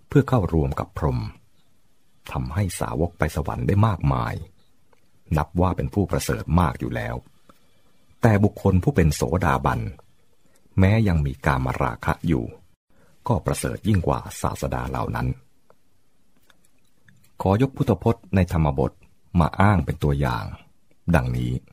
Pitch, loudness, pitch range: 85 Hz, -23 LUFS, 70-100 Hz